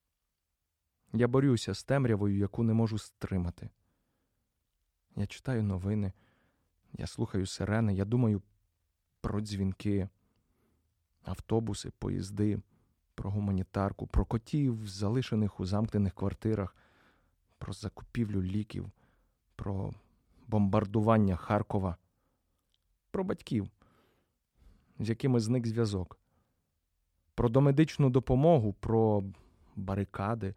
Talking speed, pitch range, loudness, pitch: 90 wpm, 95-115 Hz, -32 LUFS, 100 Hz